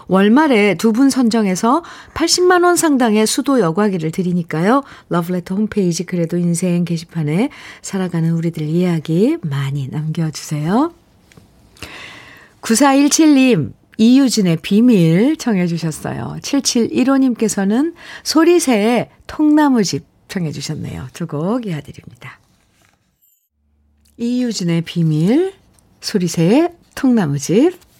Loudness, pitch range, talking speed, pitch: -15 LUFS, 165-260 Hz, 240 characters per minute, 205 Hz